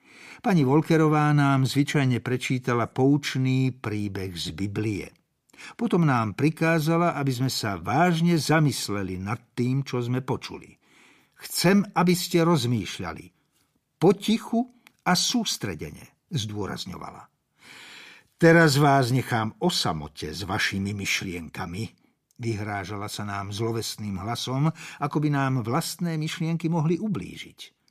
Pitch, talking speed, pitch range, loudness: 135 Hz, 105 wpm, 110-165 Hz, -25 LUFS